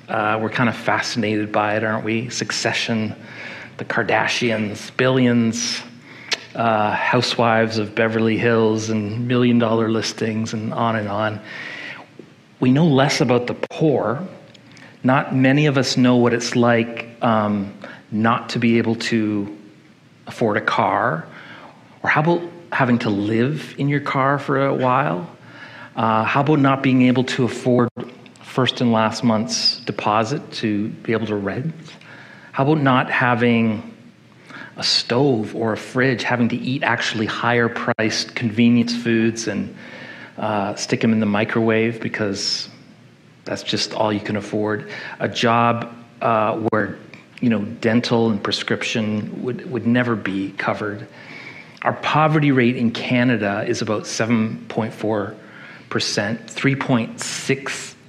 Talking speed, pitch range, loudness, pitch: 135 wpm, 110-125 Hz, -19 LUFS, 115 Hz